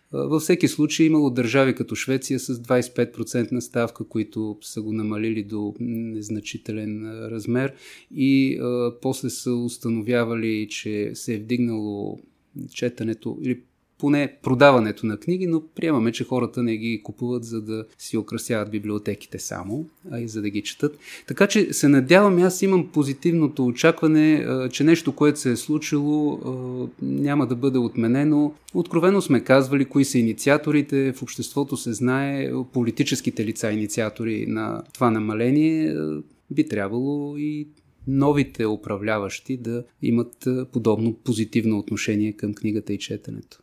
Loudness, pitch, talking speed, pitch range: -23 LUFS, 125 Hz, 135 wpm, 110-145 Hz